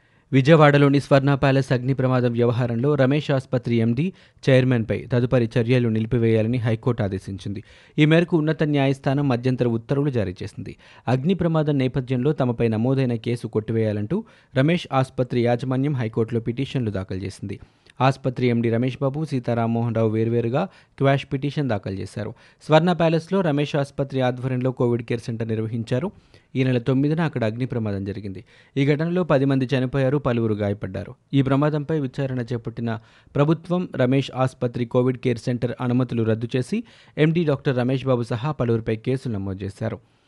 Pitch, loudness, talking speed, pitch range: 130 Hz, -22 LUFS, 140 wpm, 115-140 Hz